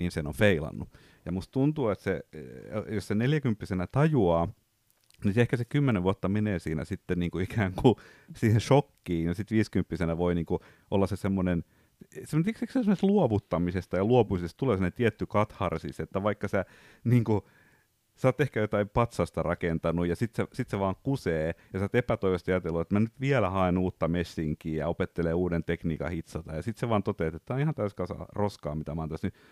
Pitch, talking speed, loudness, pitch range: 100 Hz, 195 wpm, -29 LUFS, 85-120 Hz